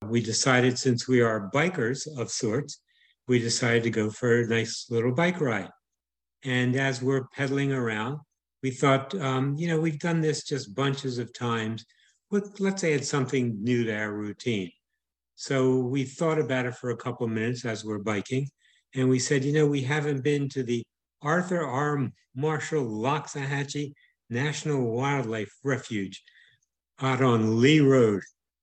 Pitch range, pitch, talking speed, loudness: 115-145 Hz, 130 Hz, 160 wpm, -27 LUFS